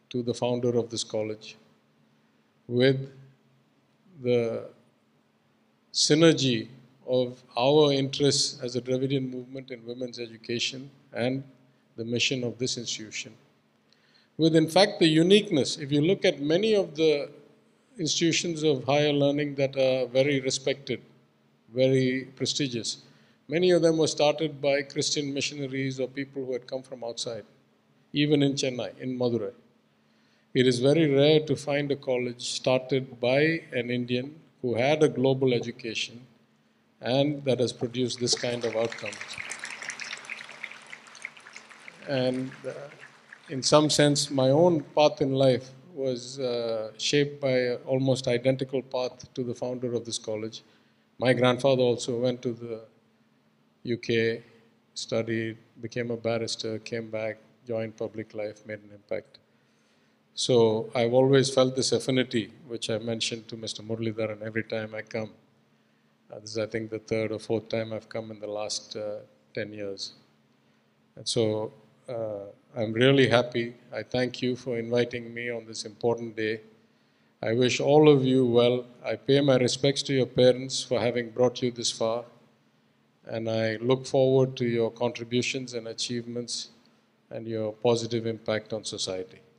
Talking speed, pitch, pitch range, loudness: 145 wpm, 125 Hz, 115-135 Hz, -27 LUFS